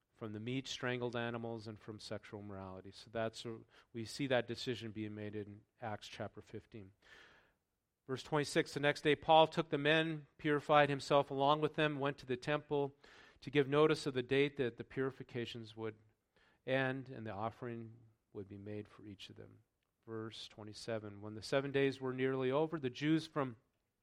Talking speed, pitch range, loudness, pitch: 180 wpm, 110-140 Hz, -37 LUFS, 120 Hz